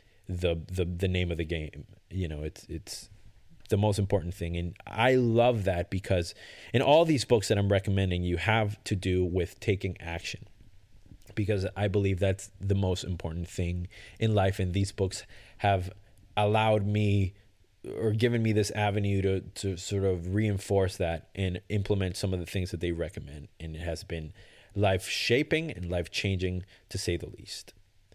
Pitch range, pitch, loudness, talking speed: 90-105 Hz, 95 Hz, -29 LUFS, 175 wpm